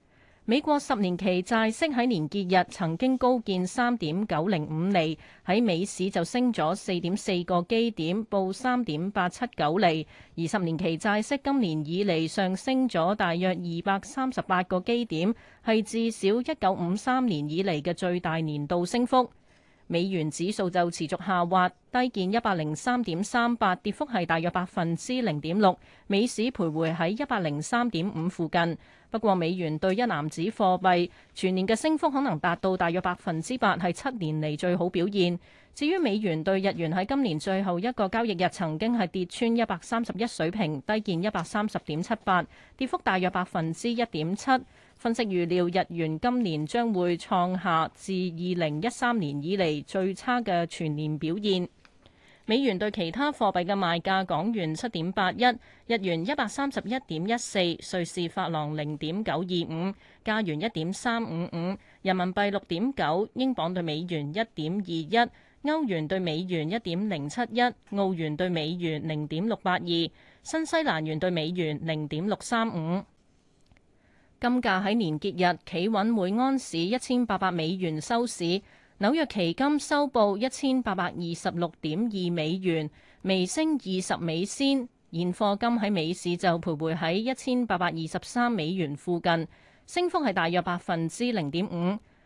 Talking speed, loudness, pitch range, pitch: 255 characters per minute, -28 LUFS, 170-230 Hz, 185 Hz